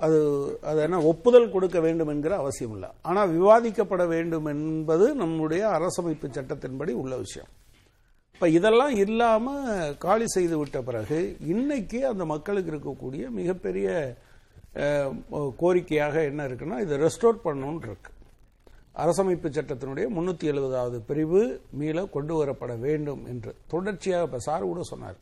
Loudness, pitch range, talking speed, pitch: -26 LUFS, 145-190 Hz, 120 wpm, 160 Hz